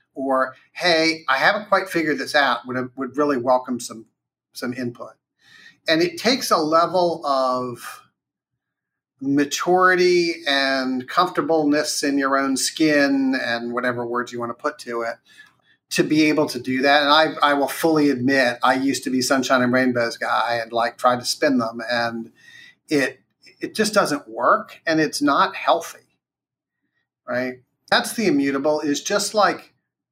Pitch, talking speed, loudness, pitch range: 140 Hz, 160 wpm, -20 LUFS, 125-165 Hz